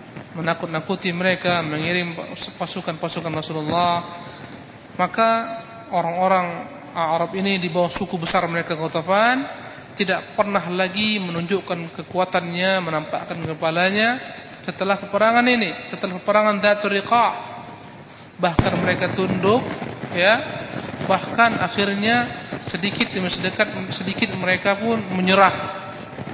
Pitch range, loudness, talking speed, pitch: 175-200 Hz, -21 LUFS, 95 wpm, 185 Hz